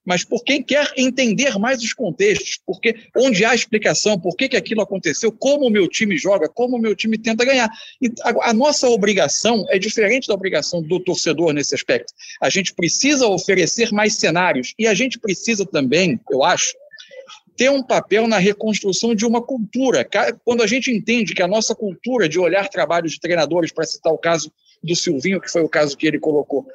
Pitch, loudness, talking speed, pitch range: 215 Hz, -18 LUFS, 190 wpm, 180-245 Hz